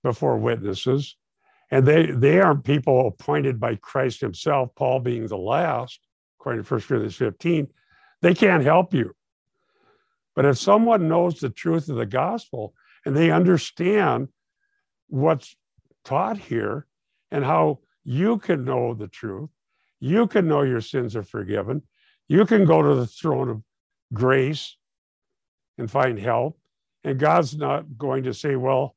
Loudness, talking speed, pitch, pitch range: -22 LUFS, 145 wpm, 145 Hz, 130-170 Hz